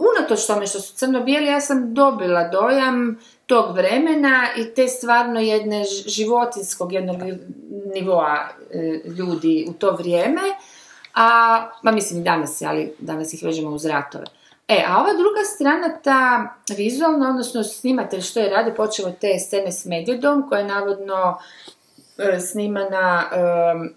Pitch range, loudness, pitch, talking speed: 180-250 Hz, -19 LUFS, 210 Hz, 145 wpm